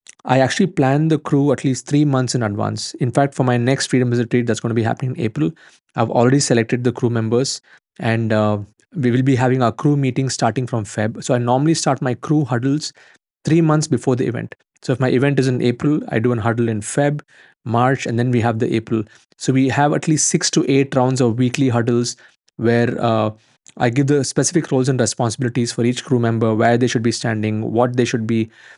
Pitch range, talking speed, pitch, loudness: 115-135 Hz, 230 wpm, 125 Hz, -18 LUFS